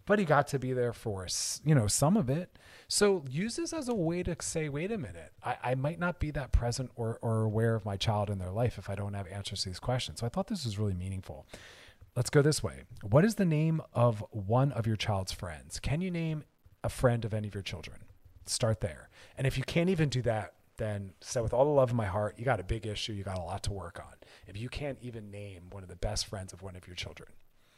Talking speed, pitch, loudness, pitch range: 265 wpm, 110 Hz, -32 LUFS, 100-135 Hz